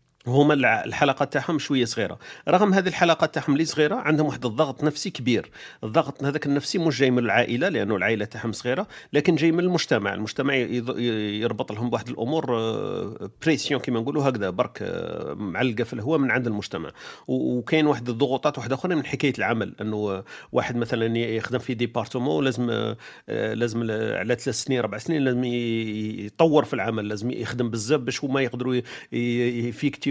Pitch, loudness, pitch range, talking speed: 125 Hz, -24 LUFS, 115-145 Hz, 160 wpm